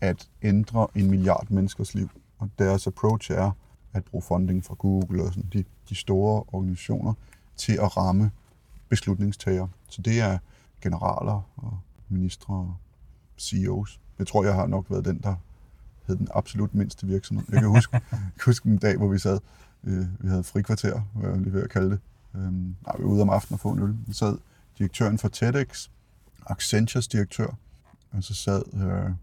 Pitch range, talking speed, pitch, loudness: 95-110 Hz, 175 wpm, 100 Hz, -26 LUFS